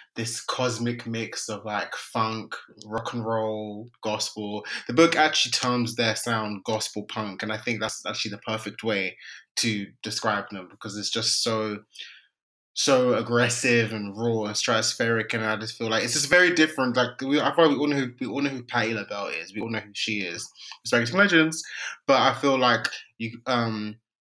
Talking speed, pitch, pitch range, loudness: 185 wpm, 115 Hz, 110-125 Hz, -25 LUFS